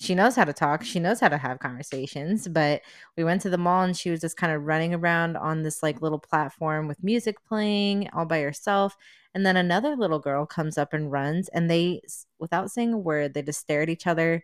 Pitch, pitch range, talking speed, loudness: 165 Hz, 150-185 Hz, 235 wpm, -26 LUFS